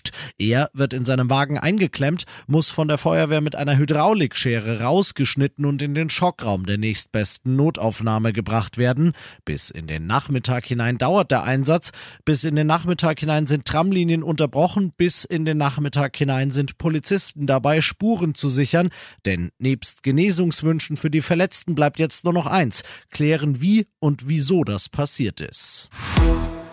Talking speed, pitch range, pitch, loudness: 155 wpm, 125-160 Hz, 145 Hz, -21 LUFS